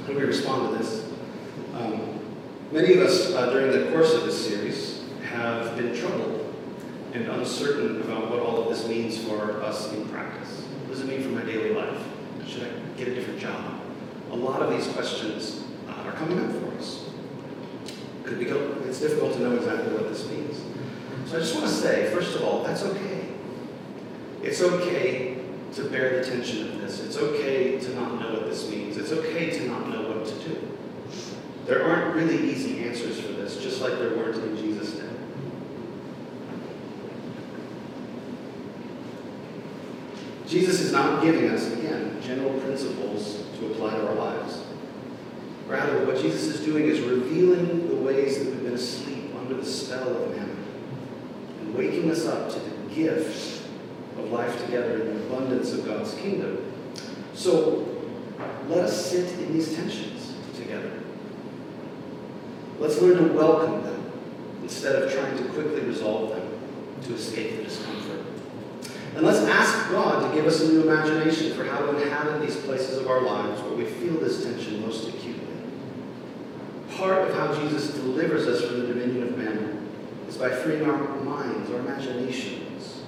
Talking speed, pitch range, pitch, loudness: 165 wpm, 120-160 Hz, 135 Hz, -27 LUFS